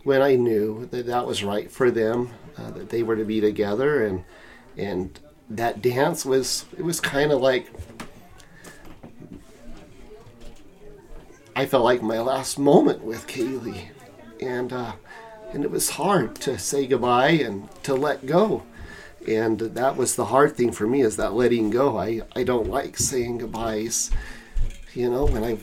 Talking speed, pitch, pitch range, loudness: 160 wpm, 120 Hz, 110-130 Hz, -23 LUFS